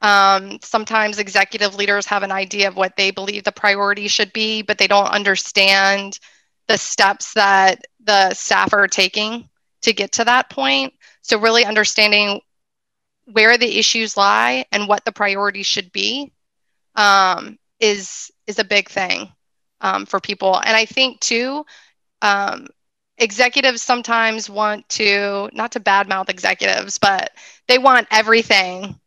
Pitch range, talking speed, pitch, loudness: 195-225 Hz, 145 wpm, 205 Hz, -16 LUFS